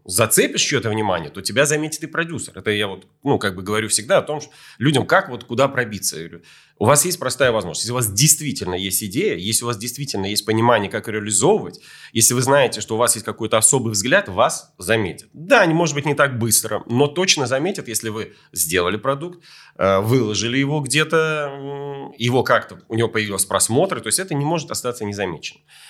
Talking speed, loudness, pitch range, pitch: 200 wpm, -19 LUFS, 105-145 Hz, 120 Hz